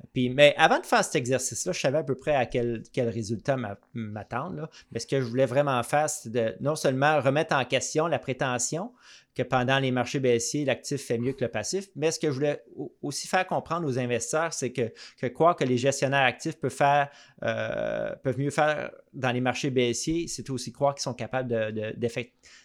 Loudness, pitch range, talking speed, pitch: -27 LUFS, 125-150 Hz, 215 wpm, 135 Hz